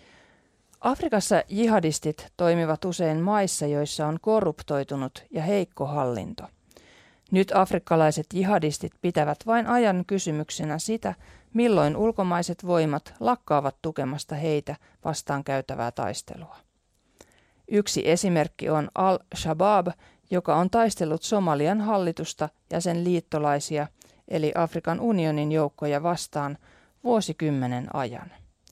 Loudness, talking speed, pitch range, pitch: -26 LUFS, 100 wpm, 150-195 Hz, 165 Hz